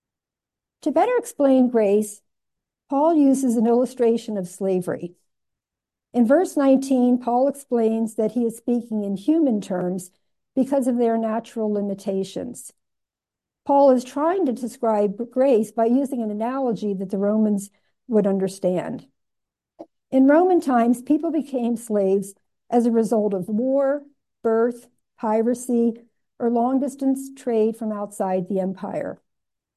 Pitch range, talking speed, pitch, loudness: 210-265 Hz, 125 wpm, 235 Hz, -21 LUFS